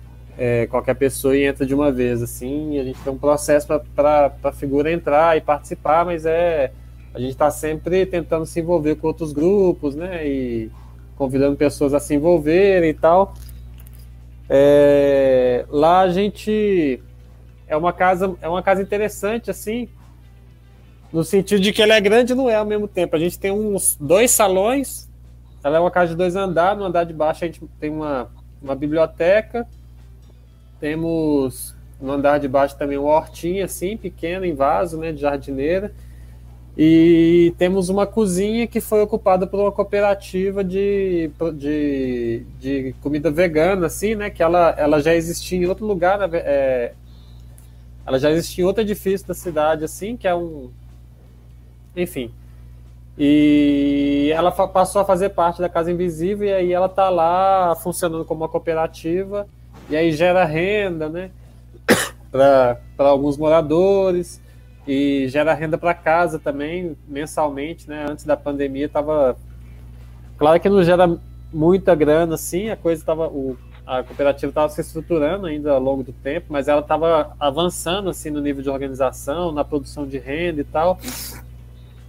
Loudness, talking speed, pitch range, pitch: -19 LUFS, 160 wpm, 135-180 Hz, 155 Hz